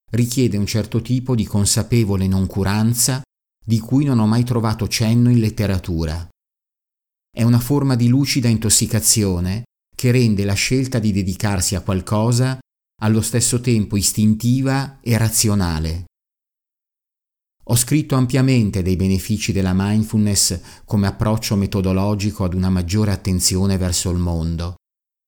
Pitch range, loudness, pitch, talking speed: 95-120 Hz, -18 LUFS, 105 Hz, 125 wpm